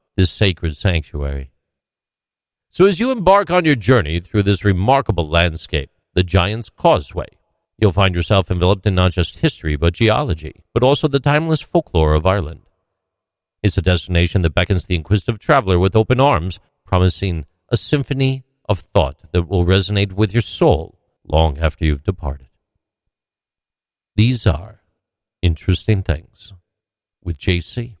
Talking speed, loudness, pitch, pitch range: 140 wpm, -17 LUFS, 95 Hz, 85-110 Hz